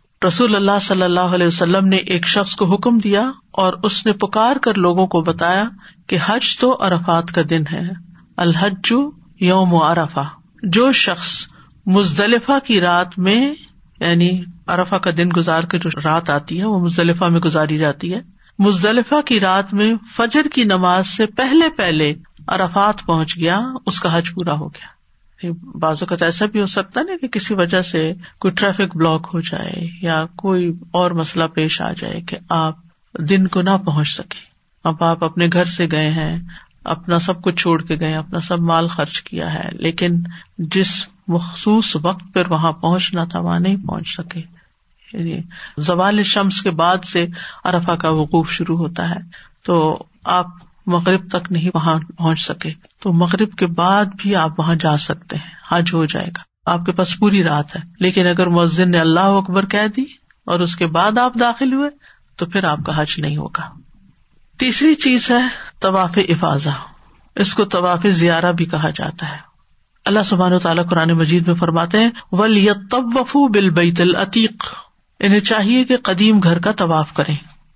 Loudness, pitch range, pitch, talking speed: -16 LUFS, 170-200 Hz, 180 Hz, 175 wpm